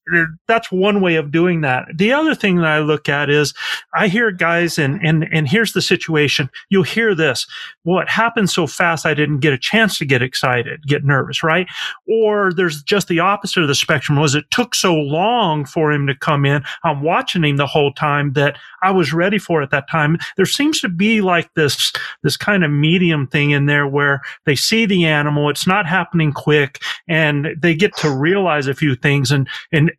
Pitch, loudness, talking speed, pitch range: 160 Hz, -16 LUFS, 215 wpm, 145-190 Hz